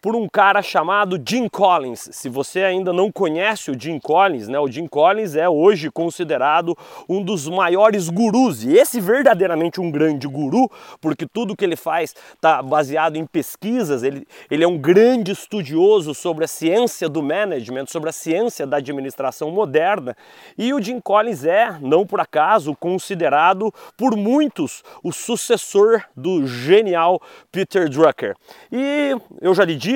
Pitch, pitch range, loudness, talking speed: 185 Hz, 160-220 Hz, -18 LUFS, 160 wpm